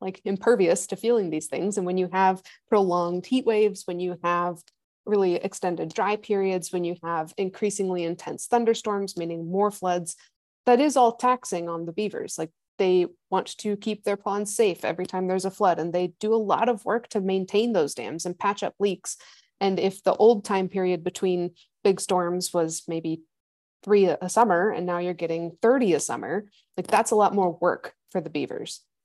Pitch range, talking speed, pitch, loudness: 175-210 Hz, 195 wpm, 190 Hz, -25 LUFS